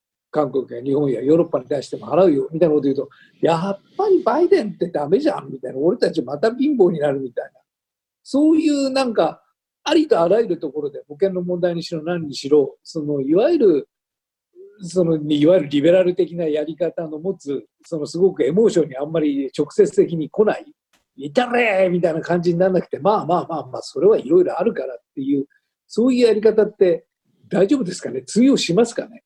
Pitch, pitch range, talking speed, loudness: 180 Hz, 150-245 Hz, 410 characters per minute, -19 LUFS